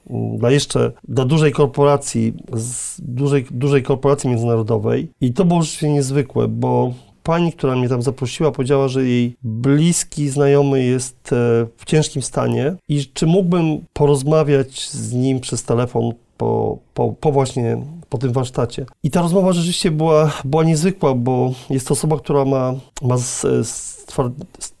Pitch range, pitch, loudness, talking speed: 125-150 Hz, 140 Hz, -18 LUFS, 150 wpm